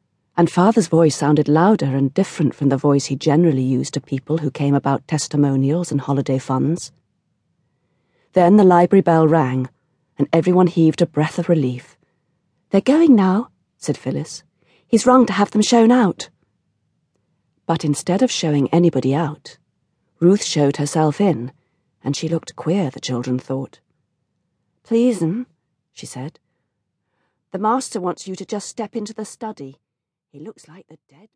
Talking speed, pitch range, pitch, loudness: 155 wpm, 140-190 Hz, 160 Hz, -18 LUFS